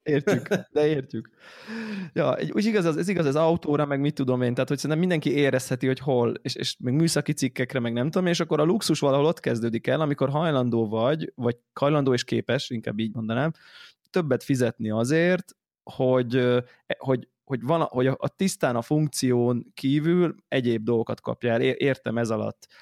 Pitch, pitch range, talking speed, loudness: 135 Hz, 120-155 Hz, 175 wpm, -25 LUFS